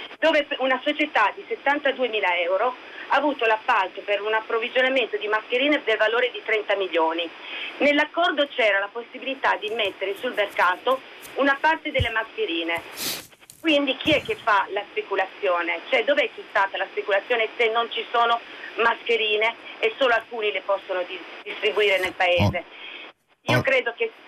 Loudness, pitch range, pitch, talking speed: -23 LUFS, 205-290 Hz, 235 Hz, 150 wpm